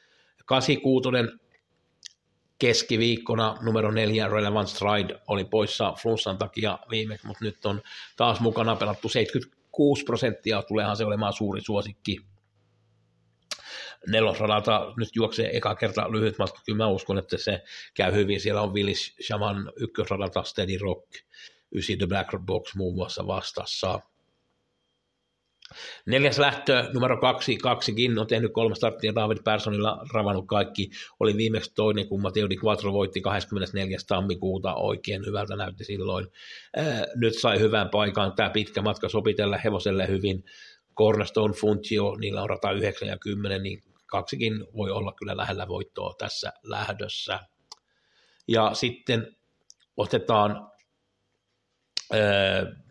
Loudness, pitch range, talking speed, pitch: -26 LUFS, 100-115 Hz, 120 wpm, 105 Hz